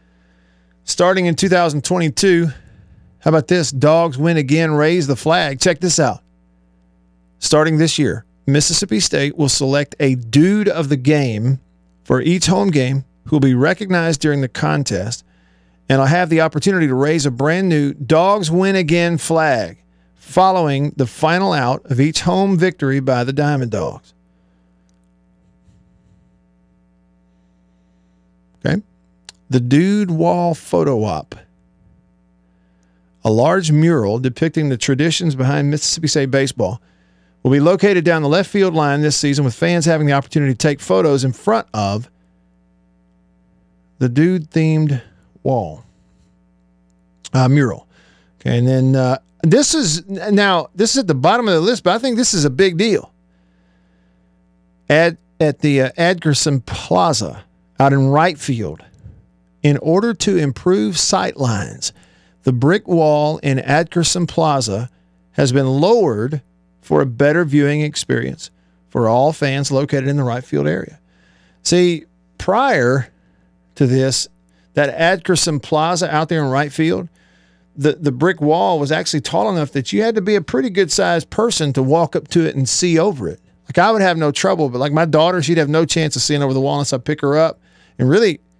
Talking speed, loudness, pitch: 160 wpm, -16 LUFS, 140 Hz